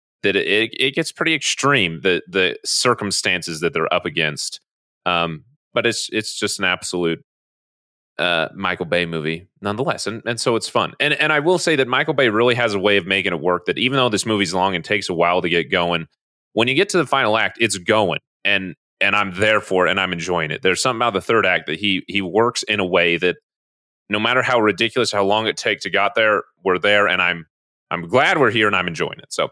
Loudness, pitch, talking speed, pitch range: -18 LUFS, 100 Hz, 235 wpm, 90-115 Hz